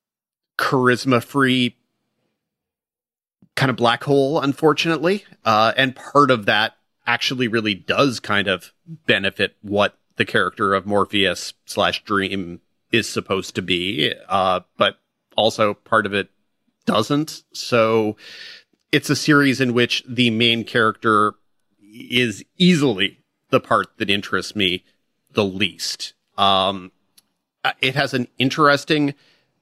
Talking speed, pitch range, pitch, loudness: 120 wpm, 100-140 Hz, 120 Hz, -19 LUFS